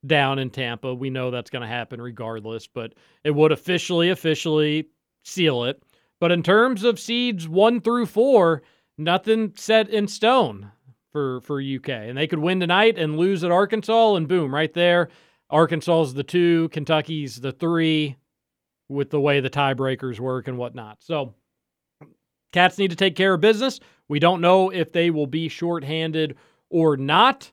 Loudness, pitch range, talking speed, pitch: -21 LUFS, 135-180 Hz, 170 wpm, 160 Hz